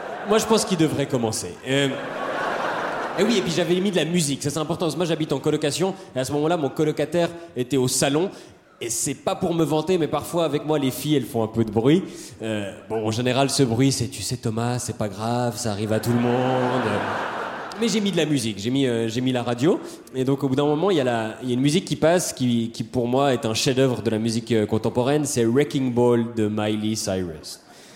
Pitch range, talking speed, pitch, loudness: 115-150 Hz, 250 wpm, 130 Hz, -23 LUFS